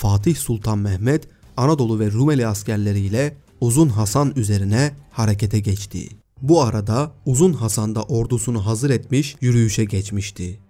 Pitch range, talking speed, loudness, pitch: 105-140 Hz, 125 wpm, -20 LUFS, 115 Hz